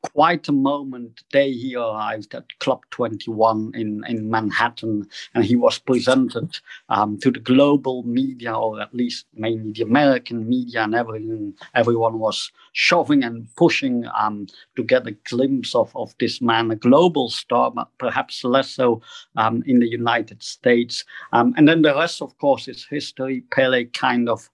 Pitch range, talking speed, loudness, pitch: 115-135 Hz, 170 wpm, -20 LUFS, 120 Hz